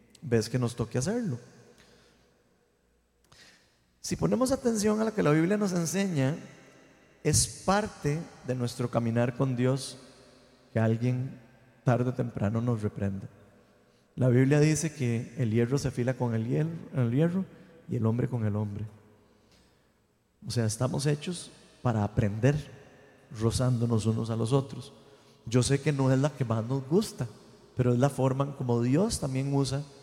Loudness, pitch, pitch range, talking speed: -29 LUFS, 125 Hz, 115-140 Hz, 155 wpm